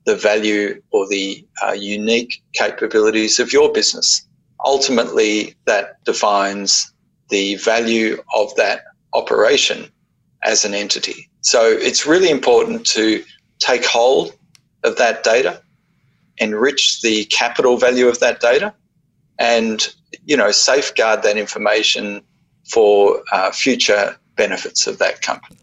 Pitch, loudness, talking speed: 120 Hz, -16 LUFS, 120 wpm